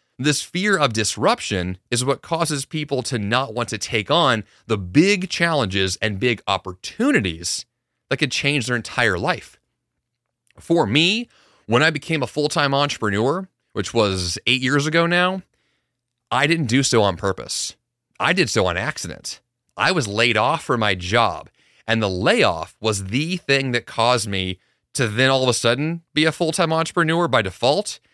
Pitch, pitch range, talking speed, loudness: 125 Hz, 110-155 Hz, 175 wpm, -20 LUFS